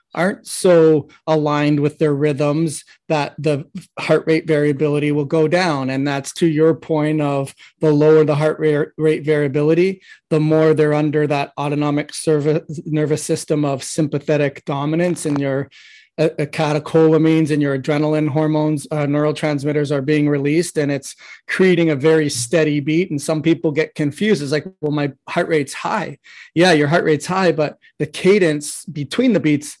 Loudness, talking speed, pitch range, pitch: -17 LUFS, 165 wpm, 150-160 Hz, 155 Hz